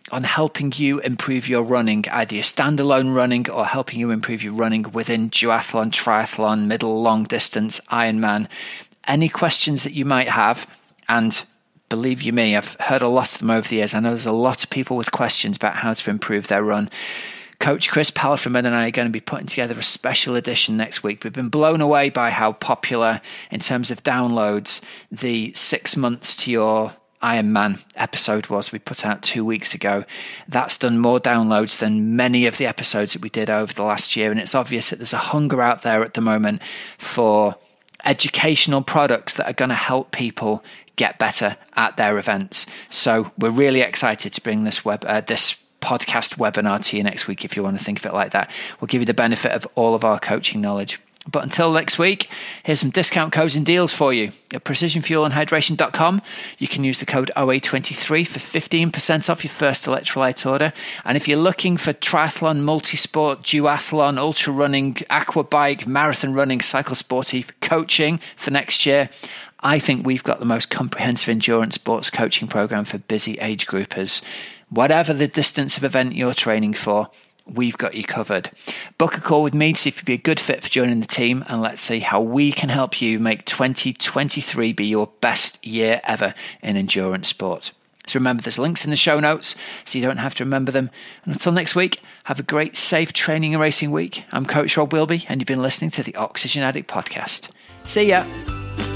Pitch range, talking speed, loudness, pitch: 110-150 Hz, 200 wpm, -19 LUFS, 130 Hz